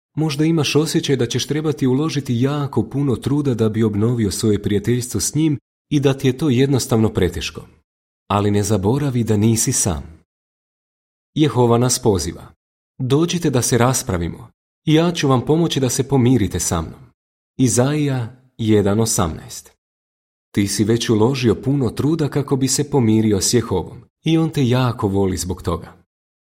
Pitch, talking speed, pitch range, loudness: 120 Hz, 150 wpm, 105-140 Hz, -18 LUFS